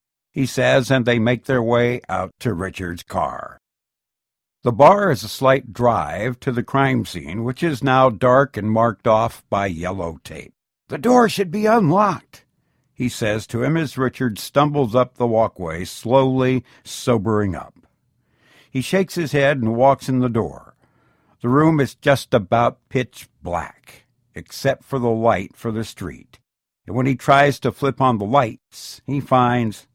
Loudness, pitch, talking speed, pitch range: -19 LUFS, 125 Hz, 165 wpm, 110-135 Hz